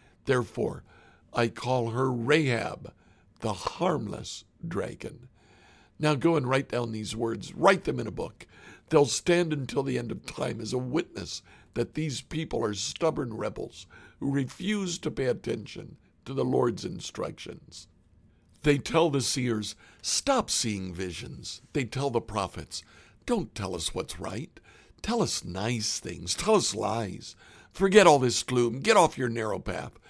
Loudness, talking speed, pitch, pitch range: -28 LUFS, 155 wpm, 120 Hz, 105-145 Hz